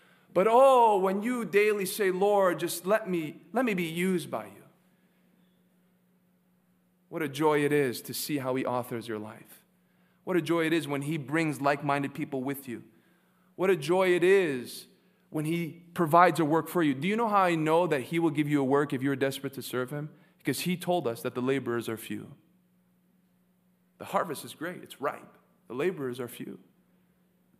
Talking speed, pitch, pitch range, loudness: 200 wpm, 175 Hz, 145-185 Hz, -28 LUFS